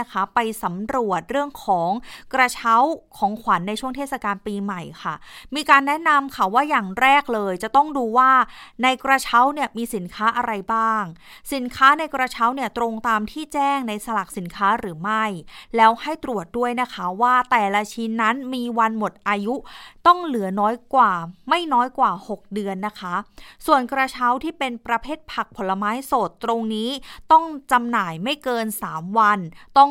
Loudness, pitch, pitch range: -21 LUFS, 235 Hz, 210-265 Hz